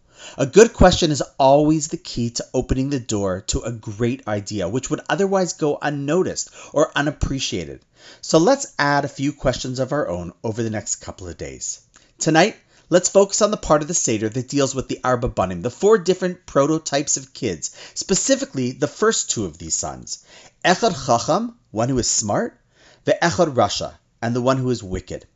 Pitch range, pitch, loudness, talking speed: 115-160 Hz, 135 Hz, -20 LUFS, 190 wpm